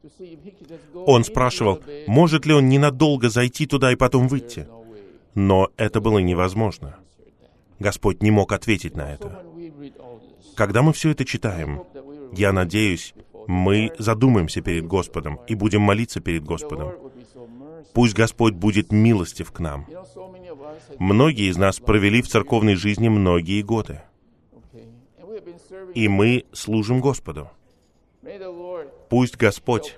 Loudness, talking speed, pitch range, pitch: -20 LUFS, 115 wpm, 100-135 Hz, 115 Hz